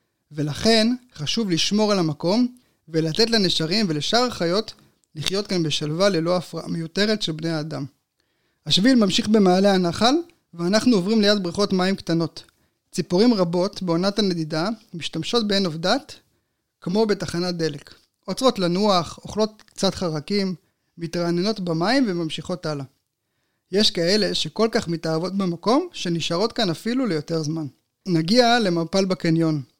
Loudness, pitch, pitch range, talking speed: -22 LUFS, 180 Hz, 160-210 Hz, 125 wpm